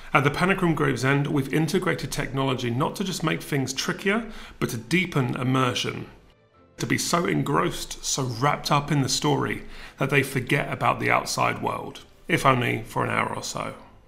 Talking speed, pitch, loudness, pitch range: 185 wpm, 145 Hz, -24 LUFS, 130-160 Hz